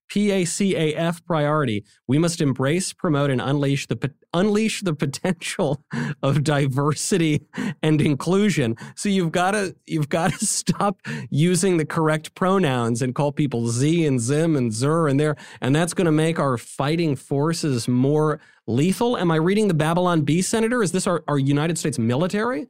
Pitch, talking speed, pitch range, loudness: 155 Hz, 165 wpm, 145-185 Hz, -22 LUFS